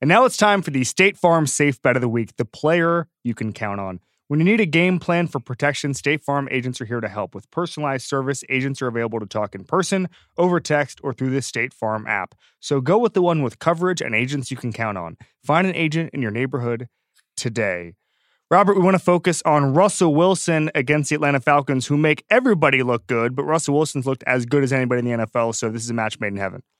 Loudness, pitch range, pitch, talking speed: -20 LUFS, 120-165 Hz, 140 Hz, 240 wpm